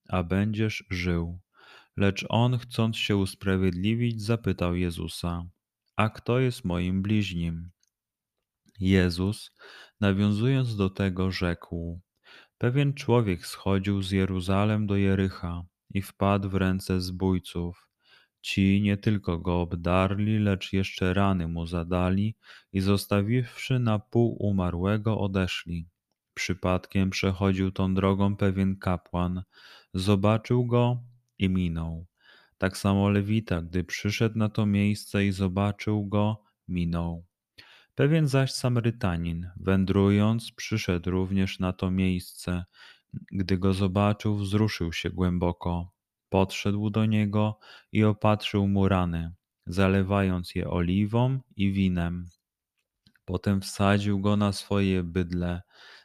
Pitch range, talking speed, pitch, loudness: 90-105 Hz, 110 wpm, 95 Hz, -27 LUFS